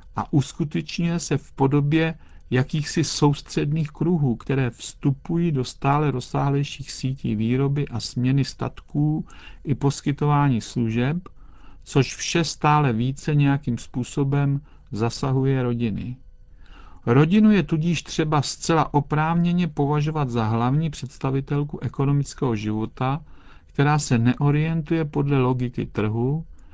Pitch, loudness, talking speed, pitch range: 140 Hz, -23 LUFS, 105 wpm, 125-150 Hz